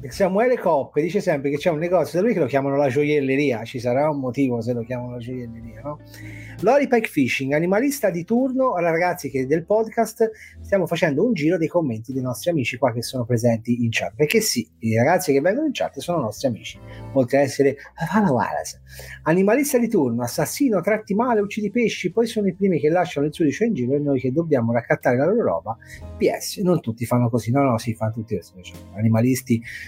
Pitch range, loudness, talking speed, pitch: 120-190 Hz, -21 LUFS, 205 wpm, 145 Hz